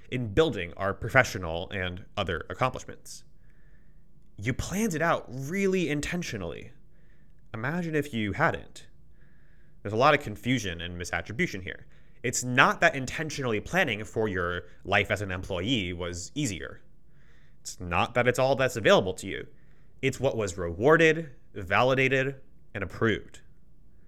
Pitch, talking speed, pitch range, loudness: 125 Hz, 135 wpm, 100-150 Hz, -27 LUFS